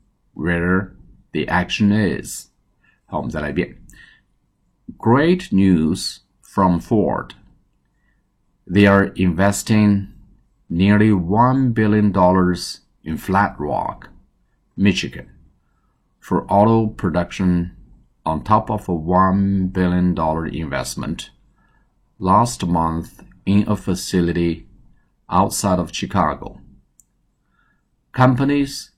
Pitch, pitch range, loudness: 95 Hz, 85-105 Hz, -18 LUFS